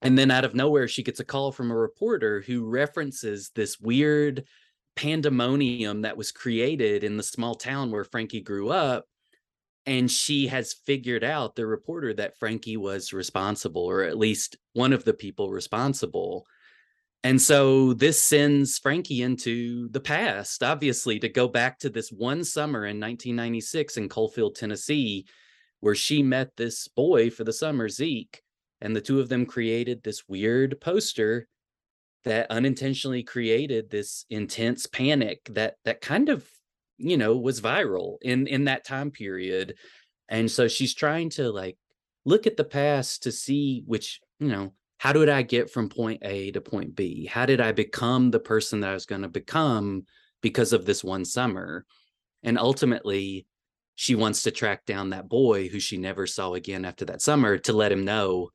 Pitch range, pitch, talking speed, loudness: 110-135 Hz, 120 Hz, 170 wpm, -26 LUFS